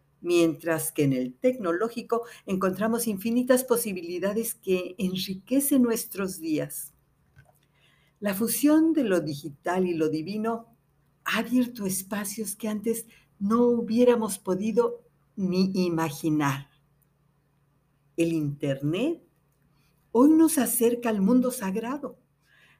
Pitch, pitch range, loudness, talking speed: 190 Hz, 155-230 Hz, -26 LUFS, 100 wpm